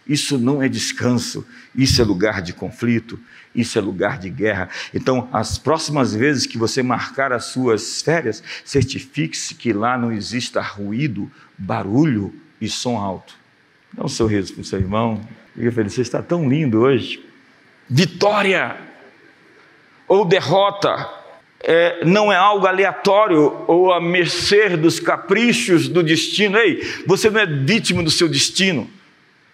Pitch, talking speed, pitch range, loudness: 145 Hz, 140 wpm, 115-185 Hz, -18 LUFS